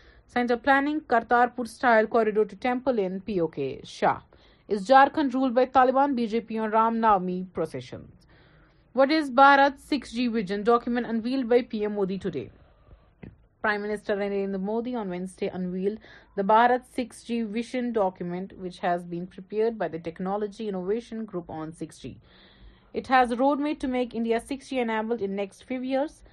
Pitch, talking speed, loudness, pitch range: 225 Hz, 155 wpm, -25 LUFS, 195-250 Hz